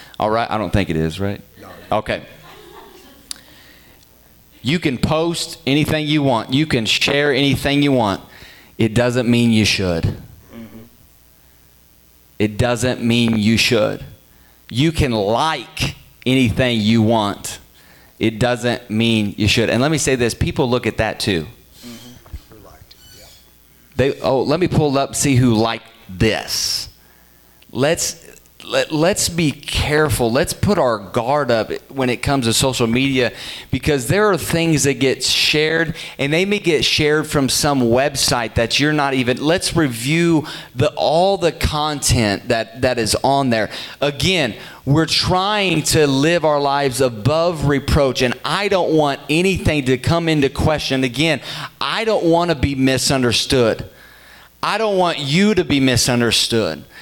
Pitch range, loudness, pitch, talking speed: 115-155 Hz, -17 LUFS, 130 Hz, 145 wpm